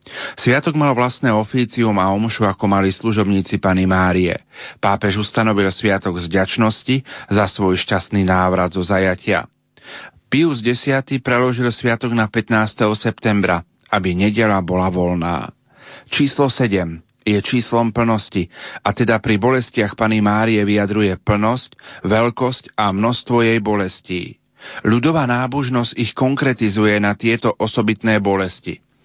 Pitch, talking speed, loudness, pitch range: 110 Hz, 120 wpm, -17 LUFS, 95-120 Hz